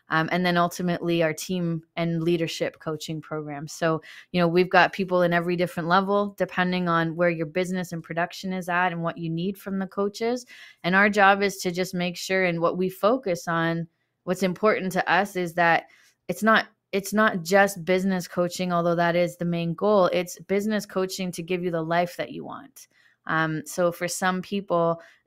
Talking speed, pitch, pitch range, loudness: 200 wpm, 175 Hz, 170-190 Hz, -24 LUFS